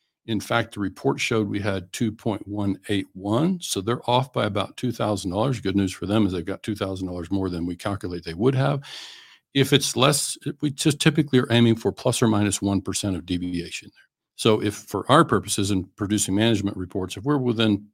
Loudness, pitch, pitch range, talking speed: -23 LUFS, 105 Hz, 95-125 Hz, 190 wpm